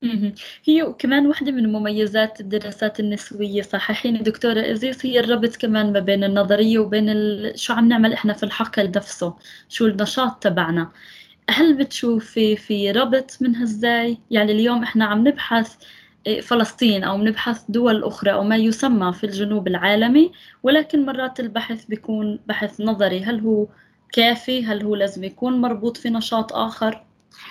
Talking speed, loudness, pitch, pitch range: 150 wpm, -20 LUFS, 220 Hz, 210-240 Hz